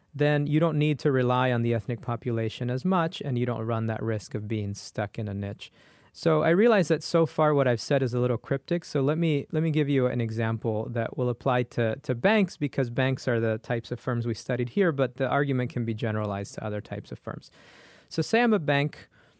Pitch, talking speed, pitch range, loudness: 125 Hz, 240 wpm, 115-150 Hz, -27 LUFS